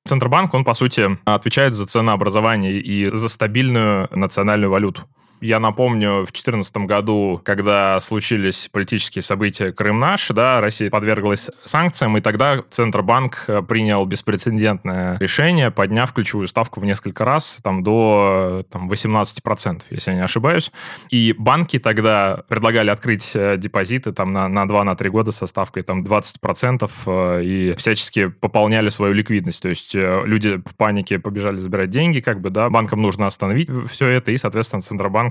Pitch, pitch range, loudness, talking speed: 105 Hz, 100-115 Hz, -18 LUFS, 150 wpm